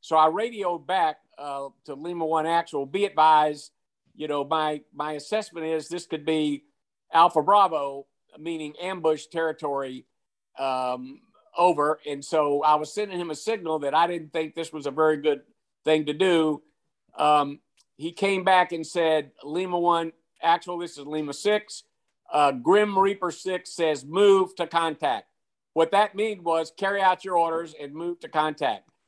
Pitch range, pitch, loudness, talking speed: 150-180 Hz, 160 Hz, -25 LUFS, 165 wpm